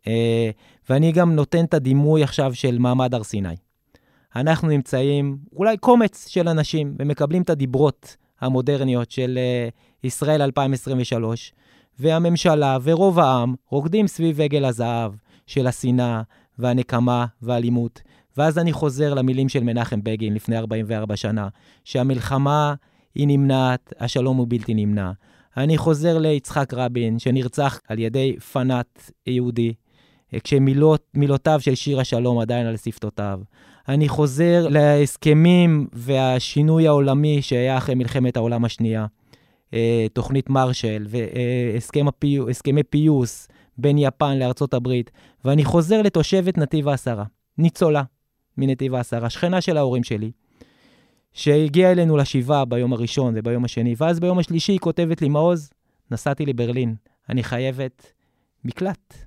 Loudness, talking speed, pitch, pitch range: -20 LUFS, 120 wpm, 135 Hz, 120-150 Hz